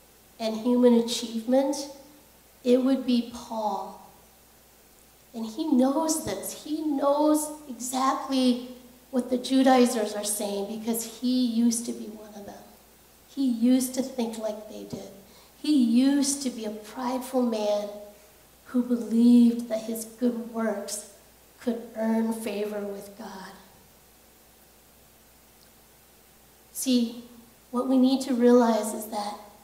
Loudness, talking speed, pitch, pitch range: -26 LUFS, 120 wpm, 240 Hz, 215-255 Hz